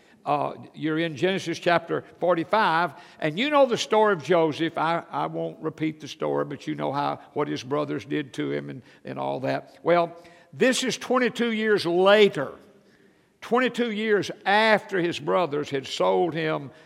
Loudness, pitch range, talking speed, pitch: -24 LUFS, 150-210 Hz, 185 wpm, 170 Hz